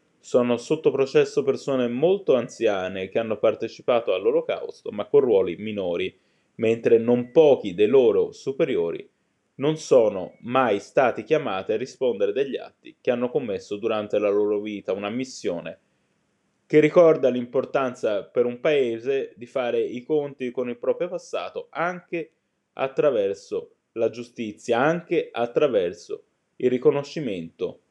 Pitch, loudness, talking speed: 390 Hz, -23 LUFS, 130 wpm